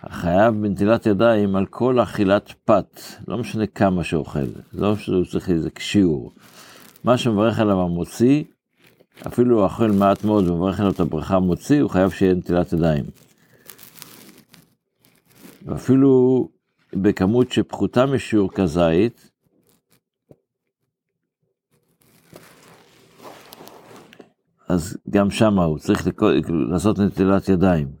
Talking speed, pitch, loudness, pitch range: 105 wpm, 100 Hz, -19 LUFS, 90-115 Hz